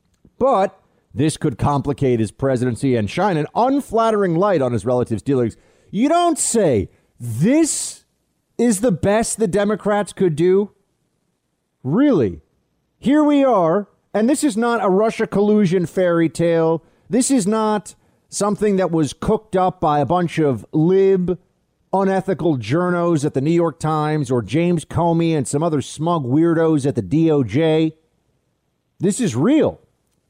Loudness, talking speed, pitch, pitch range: -18 LUFS, 145 wpm, 170 Hz, 150-205 Hz